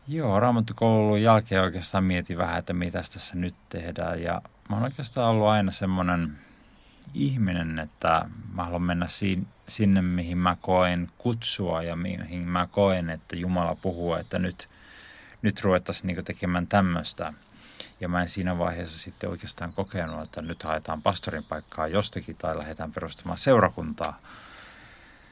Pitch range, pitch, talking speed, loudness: 85-100 Hz, 90 Hz, 145 wpm, -27 LUFS